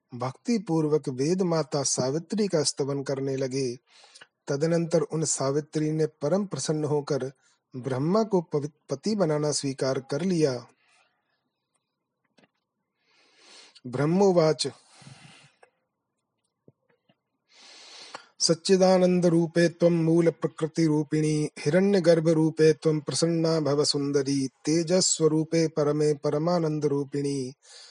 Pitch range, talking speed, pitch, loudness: 145-170 Hz, 85 wpm, 155 Hz, -25 LUFS